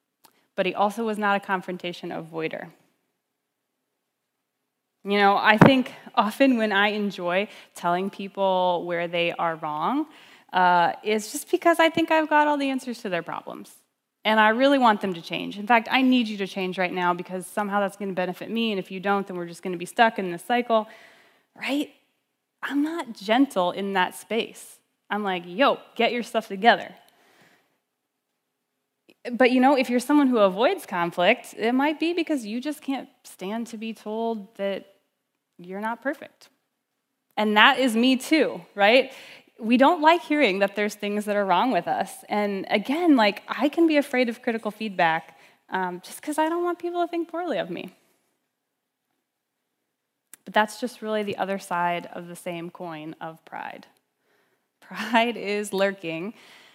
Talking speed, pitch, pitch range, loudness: 175 wpm, 215 Hz, 190-255 Hz, -23 LUFS